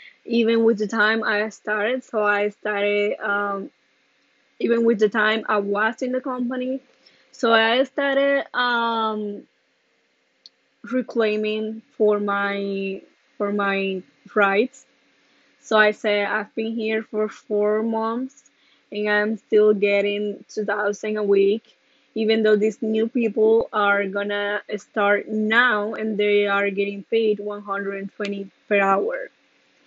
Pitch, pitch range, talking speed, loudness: 215 Hz, 205-225 Hz, 125 wpm, -22 LUFS